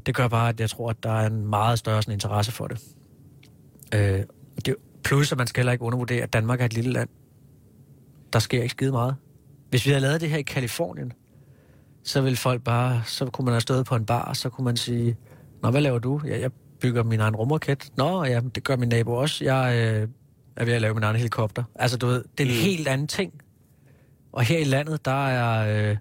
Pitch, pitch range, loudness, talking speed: 125 Hz, 115-135 Hz, -25 LUFS, 235 wpm